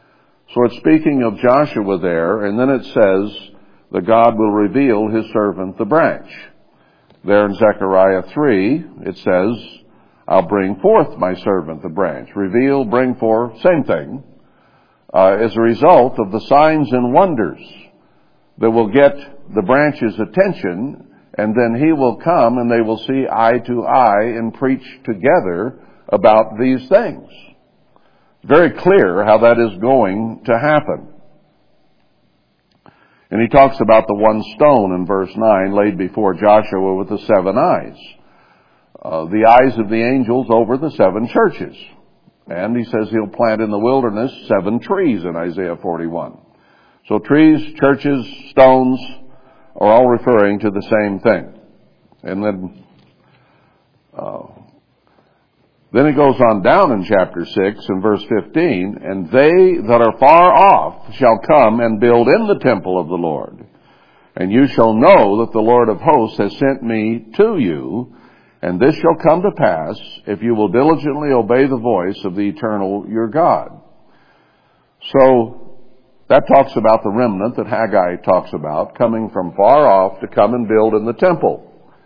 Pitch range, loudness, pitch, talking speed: 100-125 Hz, -14 LUFS, 115 Hz, 155 wpm